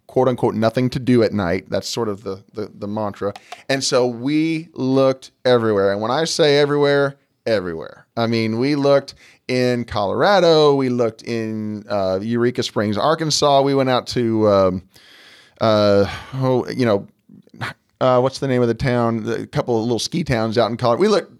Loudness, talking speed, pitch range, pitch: -18 LUFS, 180 wpm, 110-135 Hz, 120 Hz